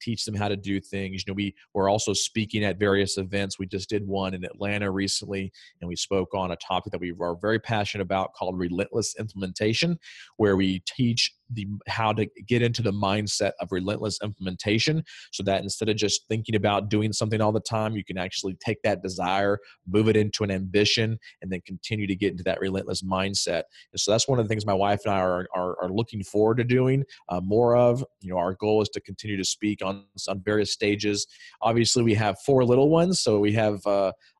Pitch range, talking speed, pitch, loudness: 95-110 Hz, 220 wpm, 100 Hz, -26 LUFS